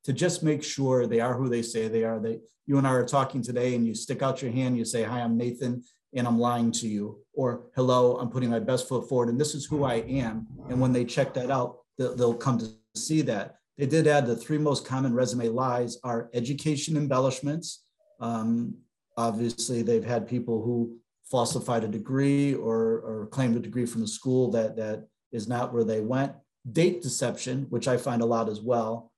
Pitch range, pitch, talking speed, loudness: 115-135 Hz, 125 Hz, 215 wpm, -28 LUFS